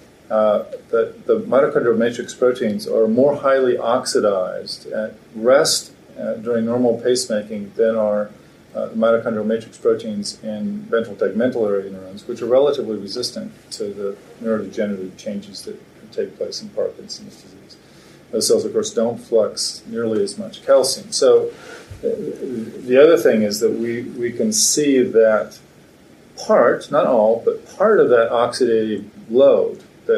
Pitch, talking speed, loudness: 125 Hz, 145 wpm, -18 LUFS